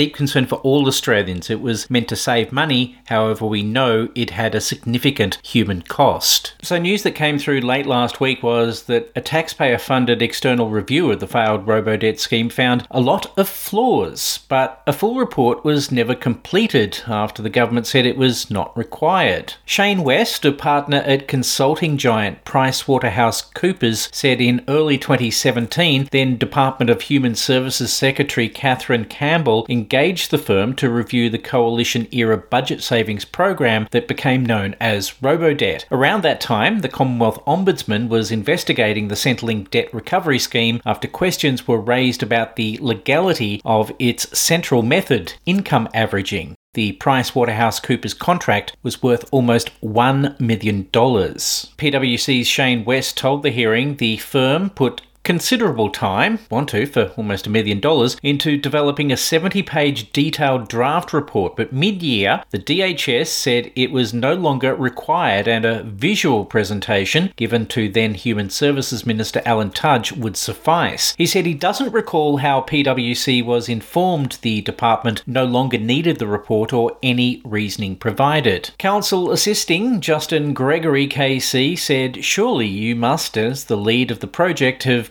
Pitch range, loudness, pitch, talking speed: 115-145 Hz, -18 LUFS, 125 Hz, 155 wpm